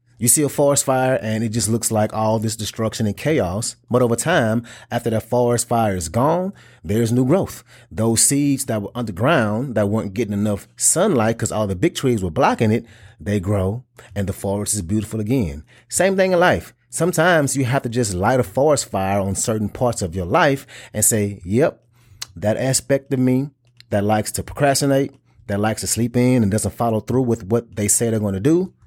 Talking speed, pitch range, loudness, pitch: 210 wpm, 105-130 Hz, -19 LUFS, 115 Hz